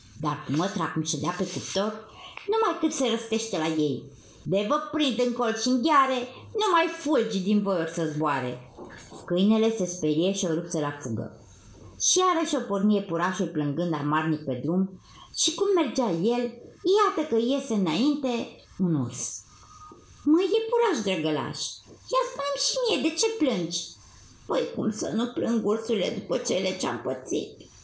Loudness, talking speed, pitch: -26 LUFS, 165 wpm, 205 Hz